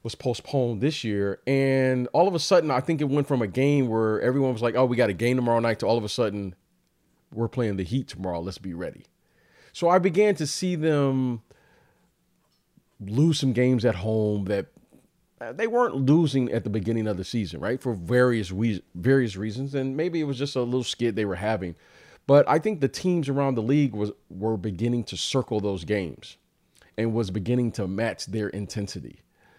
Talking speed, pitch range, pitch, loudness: 205 wpm, 105-135 Hz, 120 Hz, -25 LUFS